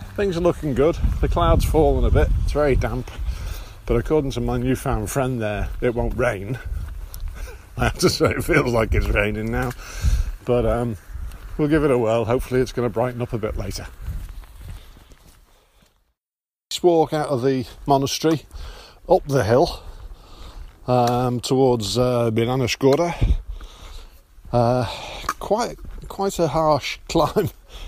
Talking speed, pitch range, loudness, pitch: 145 wpm, 90-130 Hz, -21 LUFS, 120 Hz